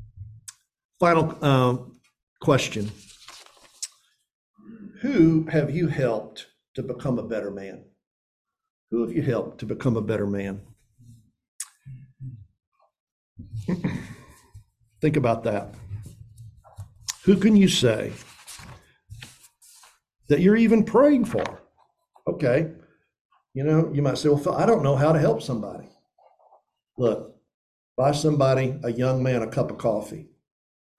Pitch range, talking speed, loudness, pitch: 110-160 Hz, 110 wpm, -23 LUFS, 130 Hz